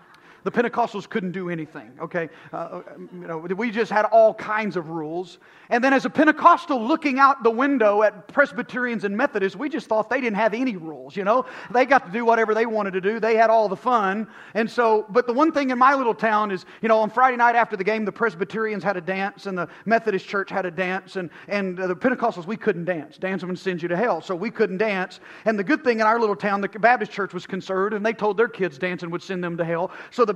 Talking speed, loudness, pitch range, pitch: 250 wpm, -22 LUFS, 190-235 Hz, 215 Hz